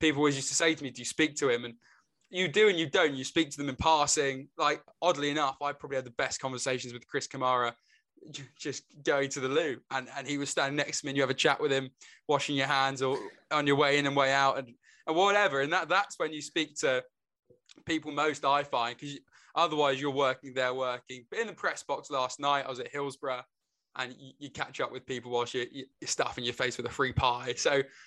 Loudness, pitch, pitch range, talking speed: -30 LUFS, 140 Hz, 130-150 Hz, 250 wpm